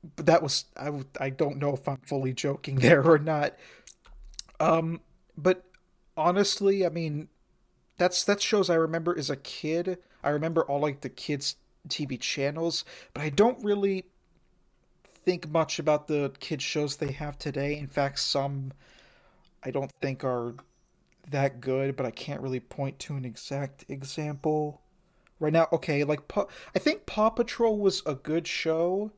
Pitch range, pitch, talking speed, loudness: 140-175 Hz, 155 Hz, 160 wpm, -28 LUFS